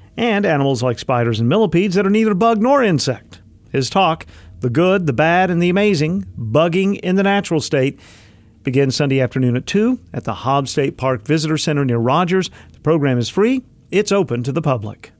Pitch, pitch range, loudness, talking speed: 150 Hz, 125-190 Hz, -17 LUFS, 195 wpm